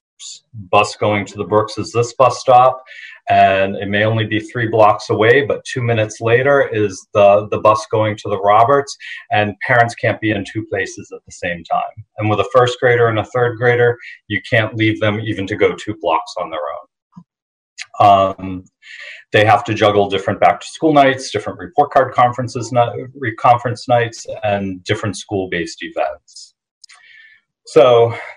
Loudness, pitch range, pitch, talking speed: -15 LUFS, 105-125 Hz, 110 Hz, 175 wpm